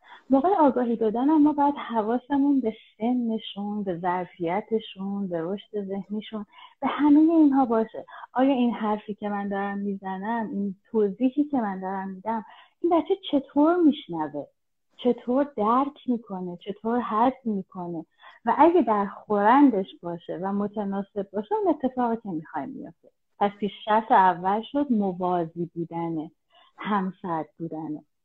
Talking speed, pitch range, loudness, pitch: 130 wpm, 190-255 Hz, -25 LUFS, 215 Hz